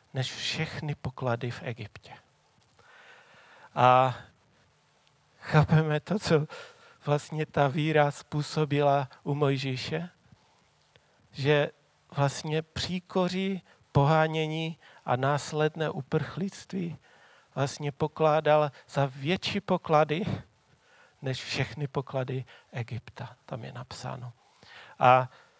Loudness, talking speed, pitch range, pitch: -28 LUFS, 80 wpm, 130-155 Hz, 145 Hz